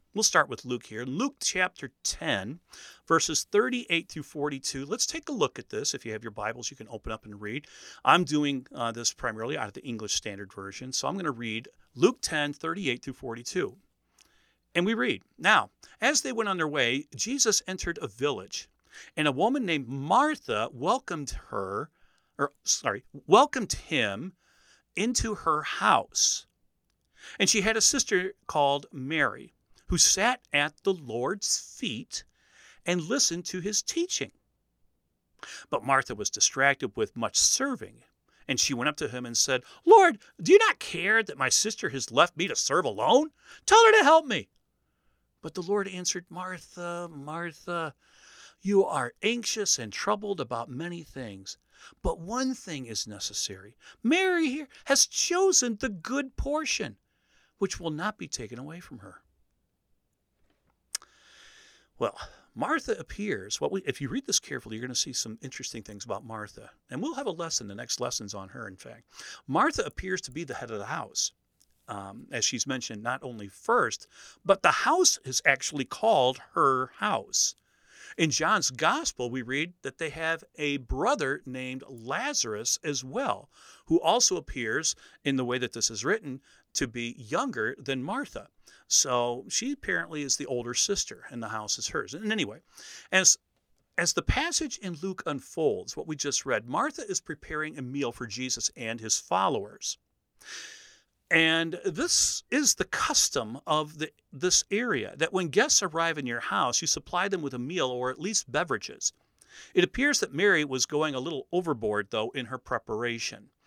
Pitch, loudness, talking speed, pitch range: 155 Hz, -27 LUFS, 170 wpm, 125-210 Hz